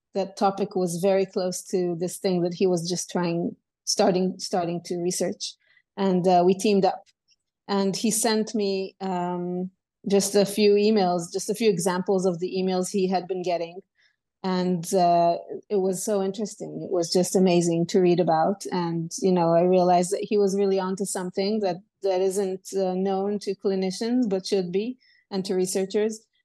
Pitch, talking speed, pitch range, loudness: 190 Hz, 180 wpm, 180-200 Hz, -24 LUFS